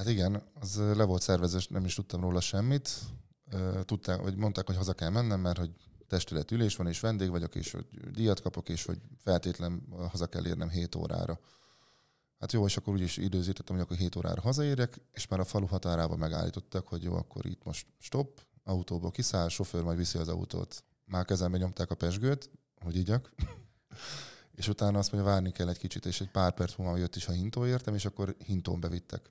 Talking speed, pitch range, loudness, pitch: 195 wpm, 90-105 Hz, -33 LUFS, 95 Hz